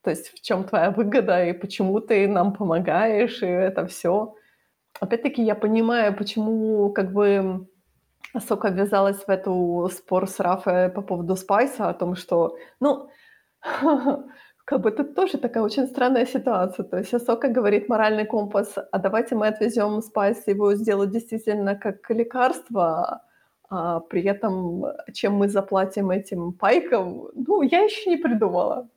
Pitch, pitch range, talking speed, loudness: 210 Hz, 190-235 Hz, 145 wpm, -23 LUFS